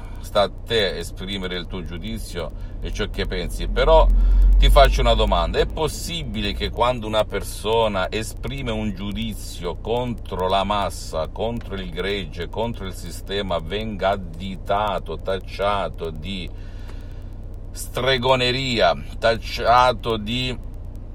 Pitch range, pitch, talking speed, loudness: 90-110 Hz, 95 Hz, 115 wpm, -22 LUFS